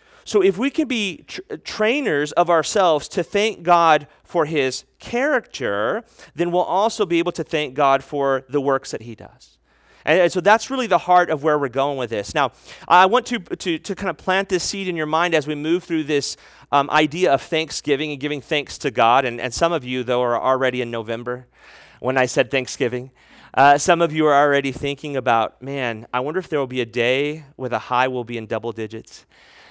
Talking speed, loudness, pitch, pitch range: 220 wpm, -20 LUFS, 150 Hz, 130-175 Hz